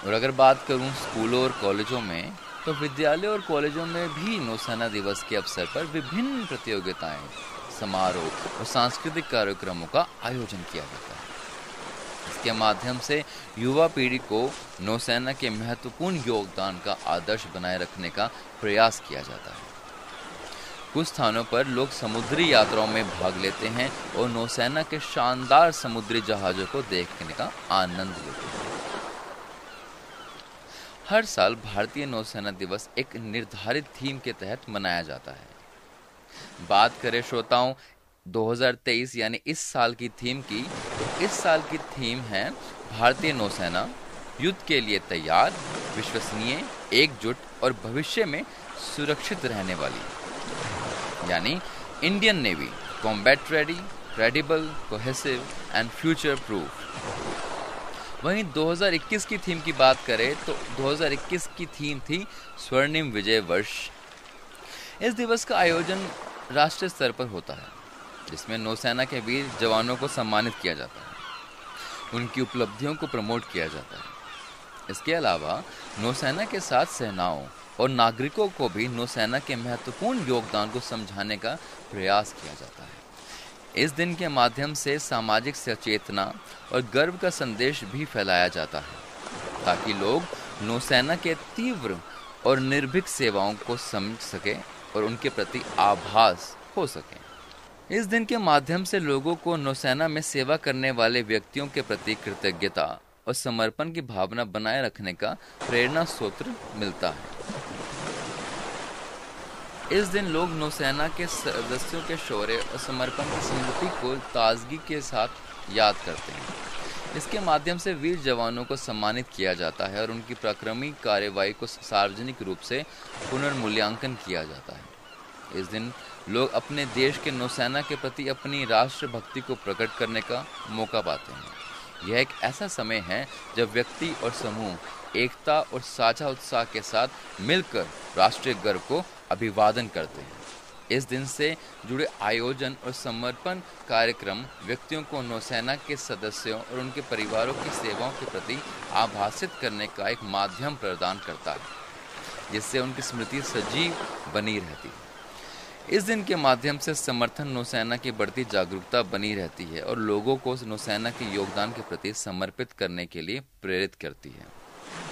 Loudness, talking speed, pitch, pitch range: -27 LUFS, 140 wpm, 125 Hz, 110-145 Hz